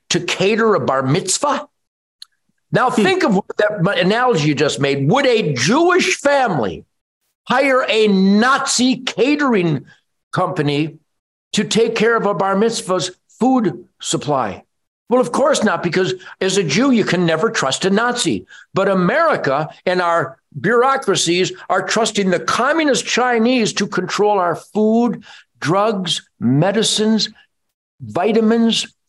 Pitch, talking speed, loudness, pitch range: 205 Hz, 130 wpm, -16 LUFS, 180-235 Hz